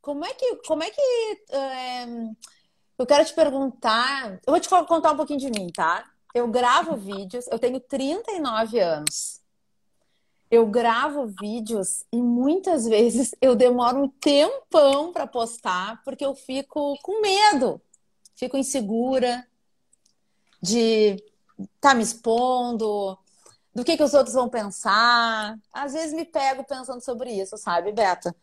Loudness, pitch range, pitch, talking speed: -23 LUFS, 220-290 Hz, 250 Hz, 140 wpm